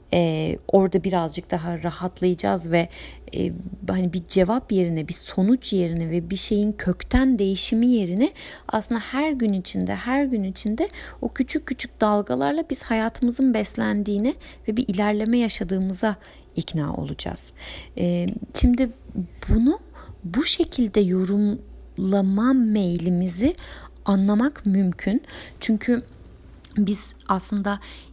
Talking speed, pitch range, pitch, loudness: 110 wpm, 180-240 Hz, 205 Hz, -23 LUFS